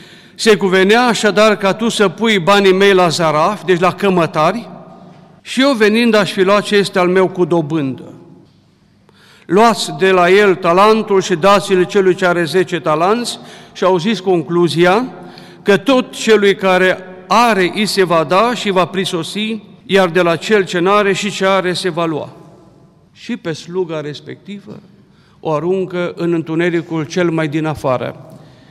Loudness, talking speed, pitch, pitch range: -13 LUFS, 165 wpm, 185 Hz, 170-205 Hz